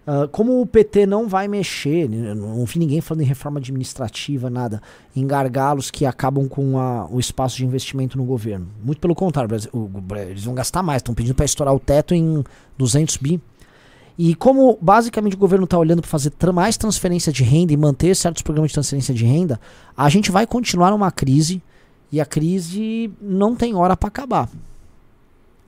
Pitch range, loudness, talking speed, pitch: 130-180 Hz, -19 LUFS, 190 wpm, 150 Hz